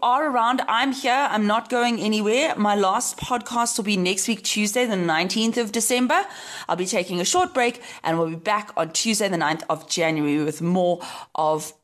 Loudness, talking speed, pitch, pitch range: -22 LUFS, 205 wpm, 210 Hz, 170-240 Hz